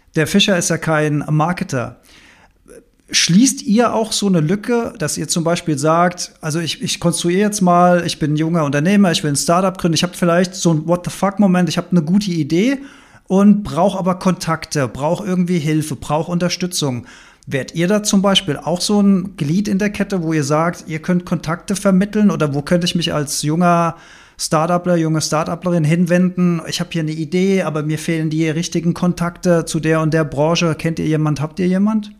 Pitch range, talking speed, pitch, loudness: 160-185 Hz, 200 wpm, 175 Hz, -16 LUFS